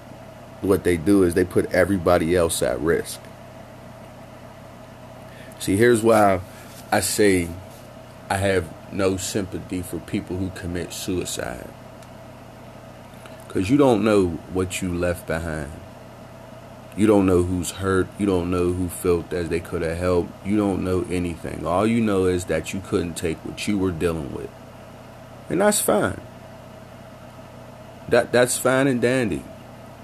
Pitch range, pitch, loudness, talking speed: 90-115 Hz, 95 Hz, -22 LUFS, 145 wpm